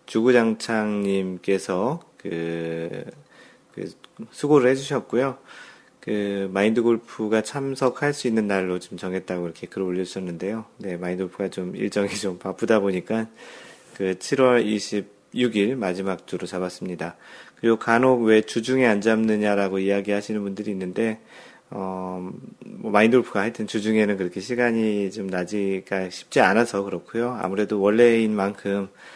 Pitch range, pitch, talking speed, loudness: 95-115 Hz, 105 Hz, 305 characters per minute, -23 LUFS